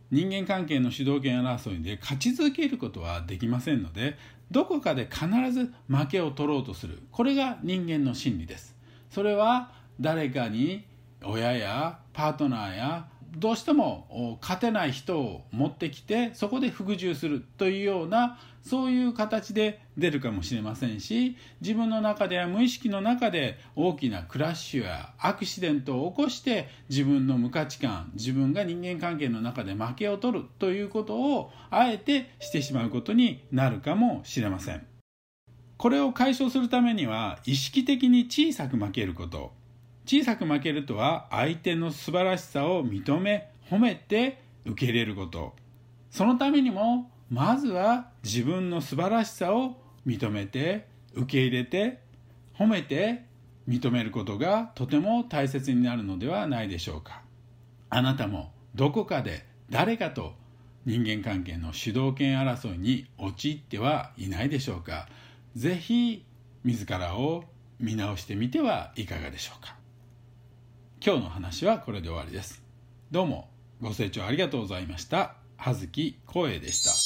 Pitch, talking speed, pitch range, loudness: 135 Hz, 305 characters per minute, 120-195 Hz, -28 LUFS